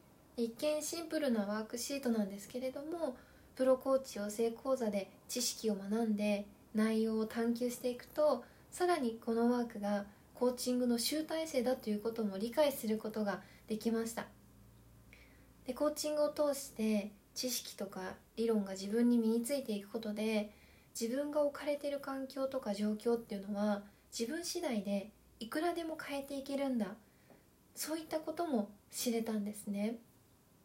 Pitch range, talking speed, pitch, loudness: 215-280 Hz, 330 characters per minute, 235 Hz, -37 LUFS